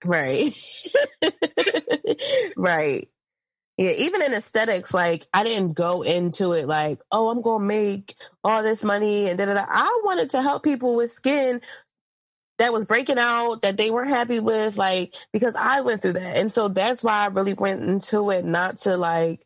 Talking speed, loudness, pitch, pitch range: 175 wpm, -22 LUFS, 215 Hz, 185-240 Hz